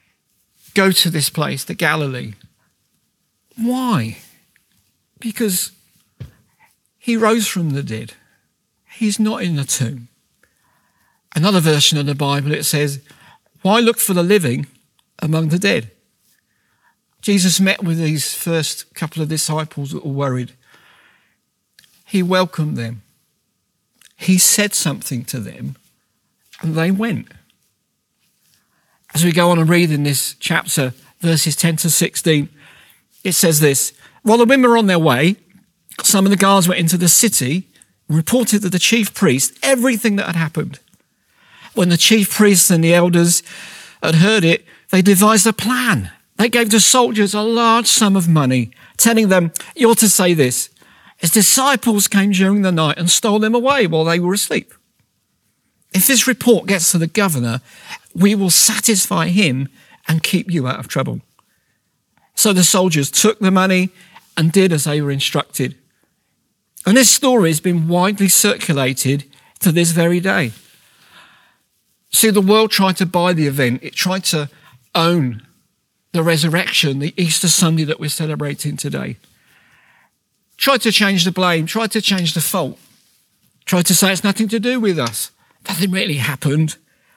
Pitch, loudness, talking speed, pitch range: 175 Hz, -15 LUFS, 155 wpm, 155-200 Hz